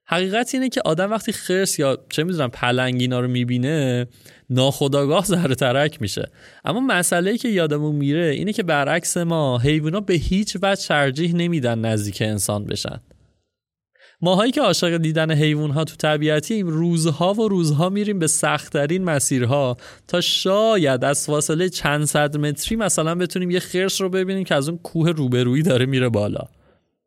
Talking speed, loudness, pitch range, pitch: 155 wpm, -20 LUFS, 140-180 Hz, 155 Hz